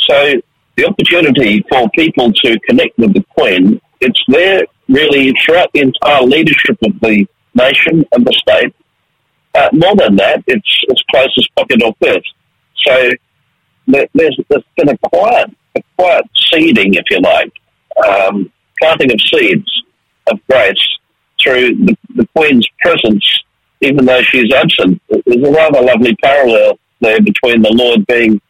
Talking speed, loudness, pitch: 150 wpm, -9 LUFS, 170 Hz